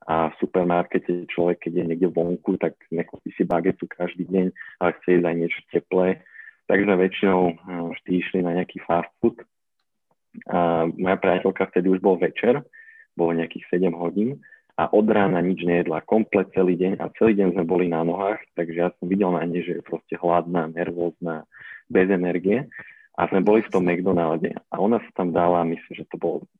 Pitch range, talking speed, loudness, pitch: 85-95 Hz, 185 wpm, -23 LUFS, 90 Hz